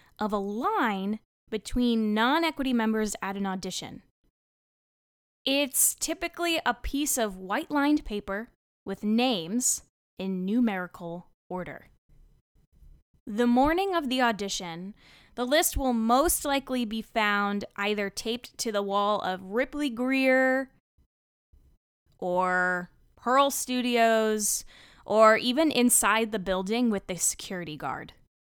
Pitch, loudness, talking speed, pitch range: 220 Hz, -26 LUFS, 115 wpm, 195-255 Hz